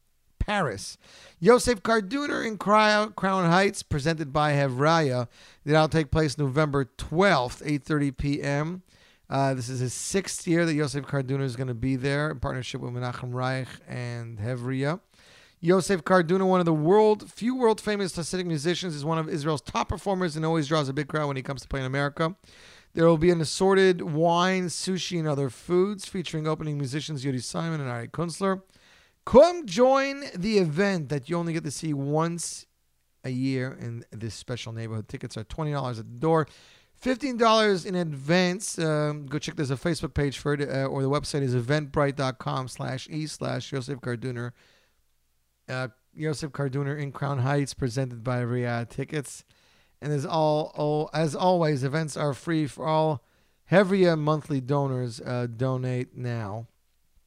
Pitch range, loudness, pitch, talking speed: 130-170 Hz, -26 LUFS, 150 Hz, 170 wpm